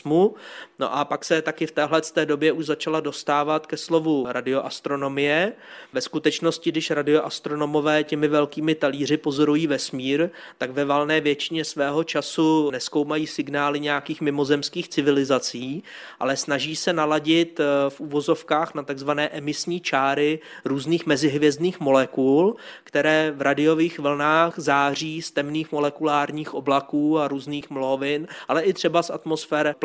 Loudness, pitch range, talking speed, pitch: -23 LUFS, 145-160 Hz, 130 wpm, 150 Hz